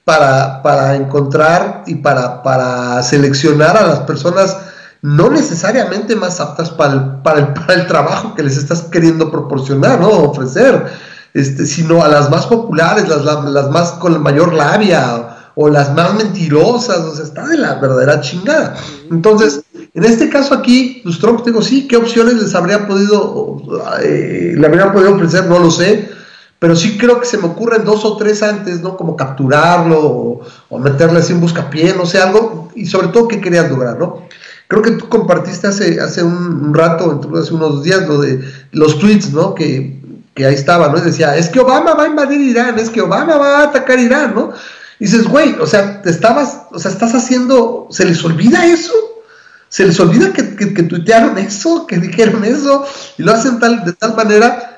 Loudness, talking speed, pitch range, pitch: -11 LUFS, 195 wpm, 155-225 Hz, 180 Hz